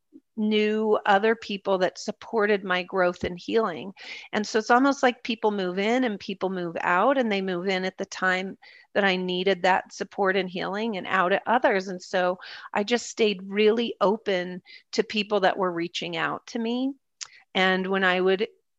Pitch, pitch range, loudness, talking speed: 200 Hz, 185-225 Hz, -25 LUFS, 185 wpm